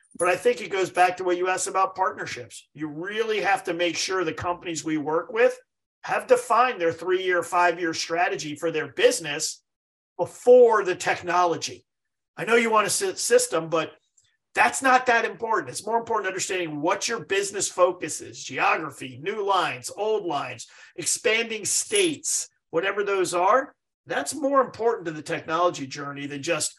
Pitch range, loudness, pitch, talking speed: 165-235 Hz, -24 LUFS, 185 Hz, 175 wpm